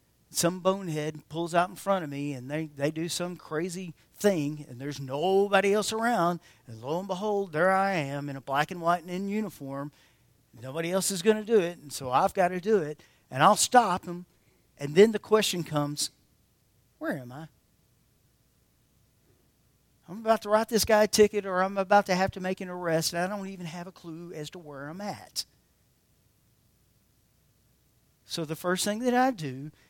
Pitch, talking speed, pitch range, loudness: 175 Hz, 195 wpm, 145-195 Hz, -28 LUFS